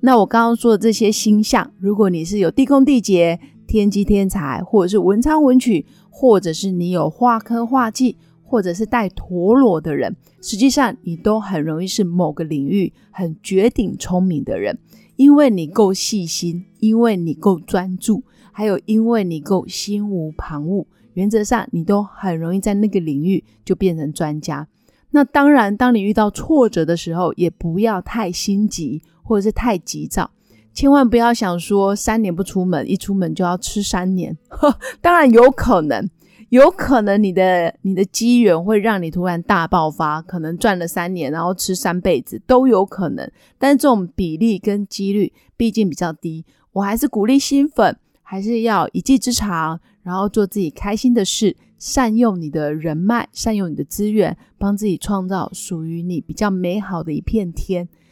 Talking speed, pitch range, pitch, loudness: 260 characters per minute, 175-230 Hz, 200 Hz, -17 LUFS